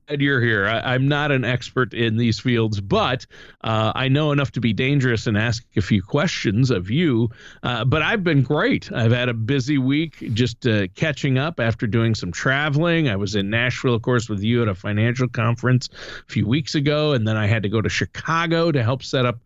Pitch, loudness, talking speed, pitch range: 125 Hz, -20 LUFS, 220 wpm, 115-140 Hz